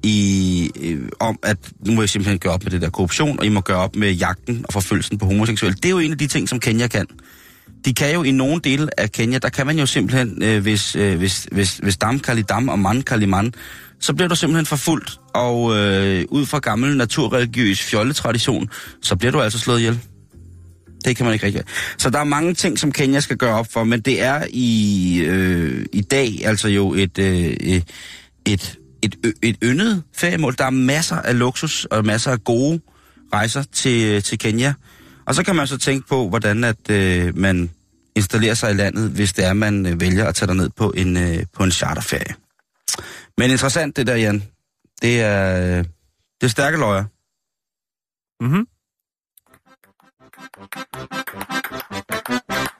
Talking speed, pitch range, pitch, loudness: 185 wpm, 95-130 Hz, 110 Hz, -19 LUFS